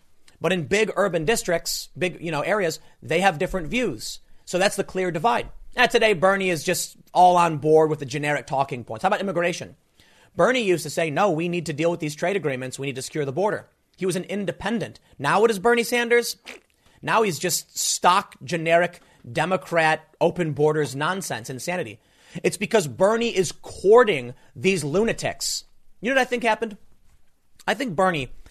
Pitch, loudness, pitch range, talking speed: 175 Hz, -23 LUFS, 155-200 Hz, 185 wpm